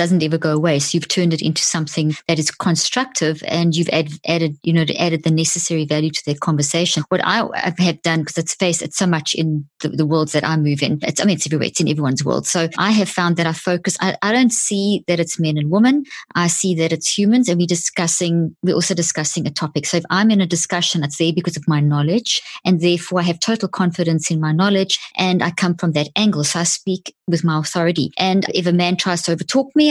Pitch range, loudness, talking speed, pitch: 160-185 Hz, -18 LUFS, 245 wpm, 170 Hz